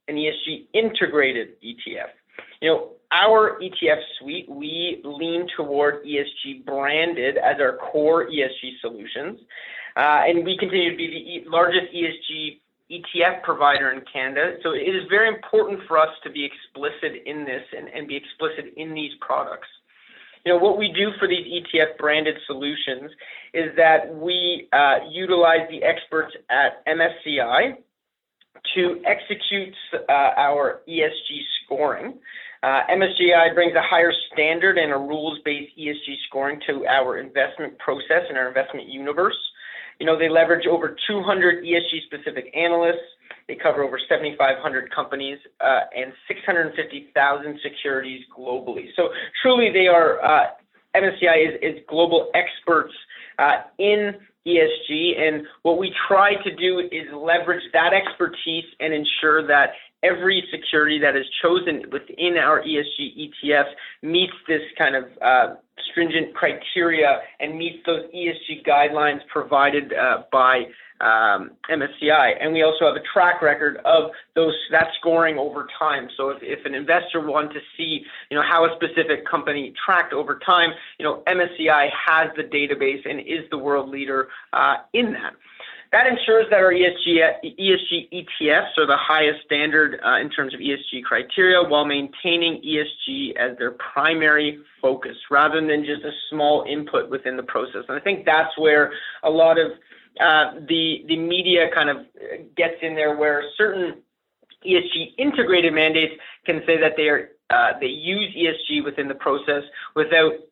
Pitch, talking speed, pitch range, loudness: 160 Hz, 150 wpm, 150-175 Hz, -20 LUFS